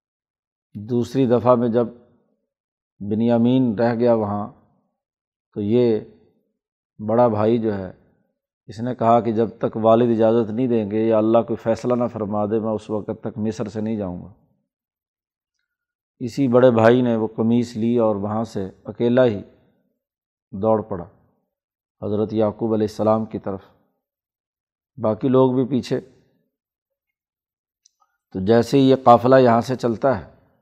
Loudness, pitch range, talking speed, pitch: -19 LUFS, 110-125 Hz, 145 wpm, 115 Hz